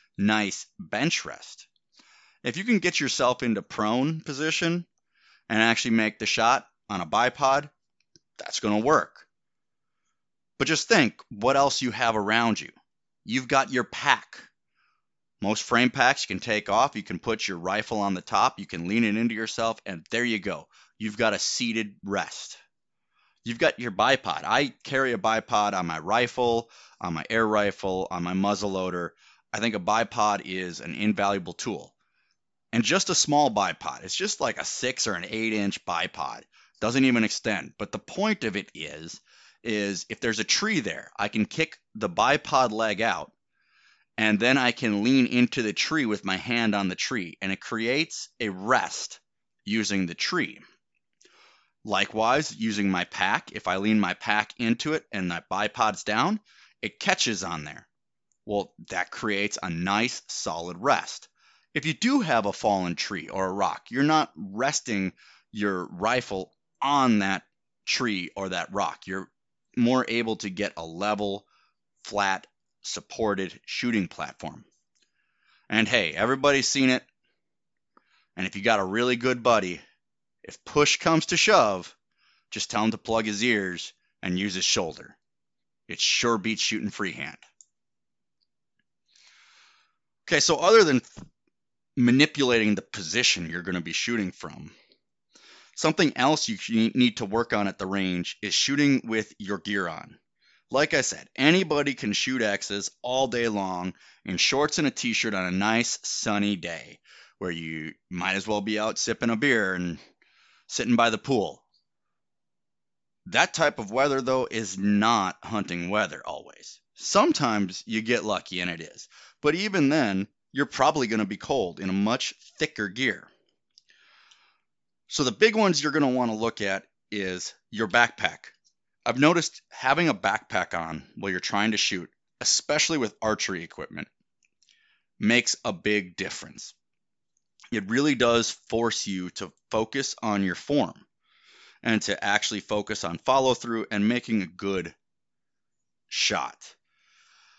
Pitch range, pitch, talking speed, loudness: 95-125 Hz, 110 Hz, 160 wpm, -26 LUFS